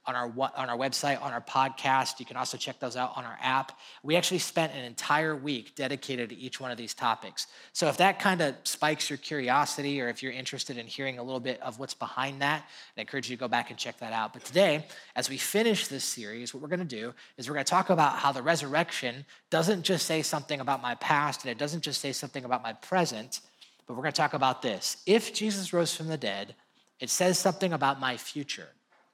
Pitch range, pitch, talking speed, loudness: 130-160 Hz, 140 Hz, 235 wpm, -30 LUFS